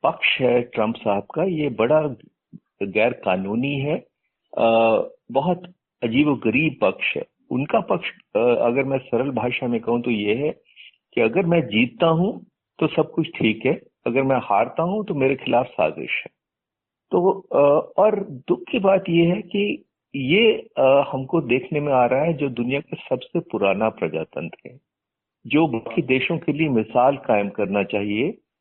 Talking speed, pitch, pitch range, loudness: 160 wpm, 140 Hz, 120-170 Hz, -21 LUFS